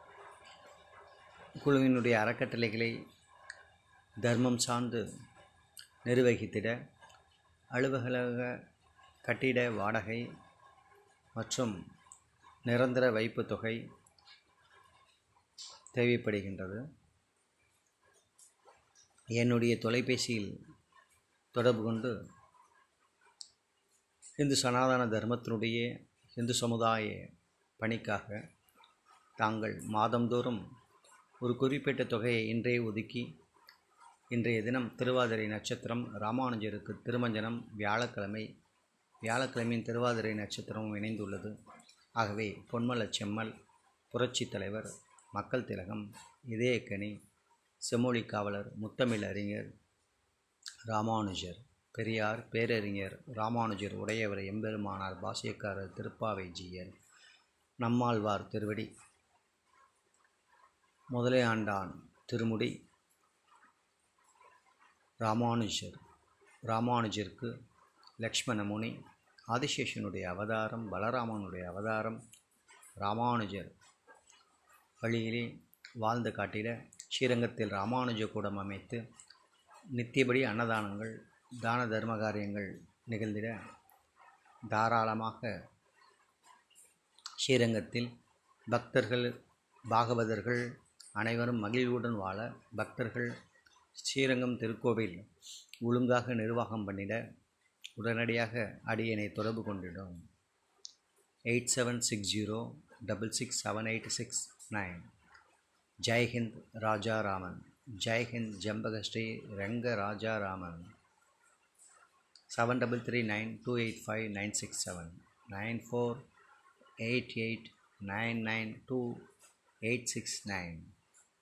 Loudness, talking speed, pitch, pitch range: -35 LUFS, 70 wpm, 115 Hz, 105-120 Hz